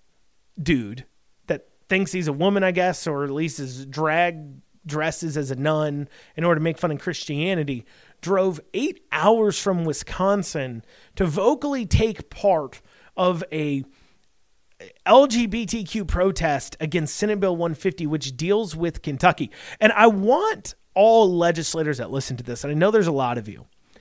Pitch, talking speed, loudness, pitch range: 170 Hz, 155 wpm, -22 LUFS, 150-200 Hz